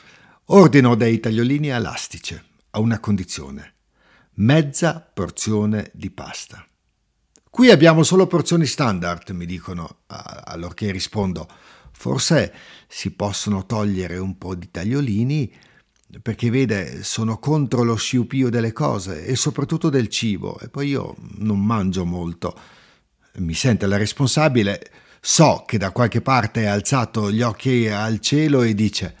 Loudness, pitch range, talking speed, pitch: -19 LUFS, 100-135 Hz, 130 wpm, 110 Hz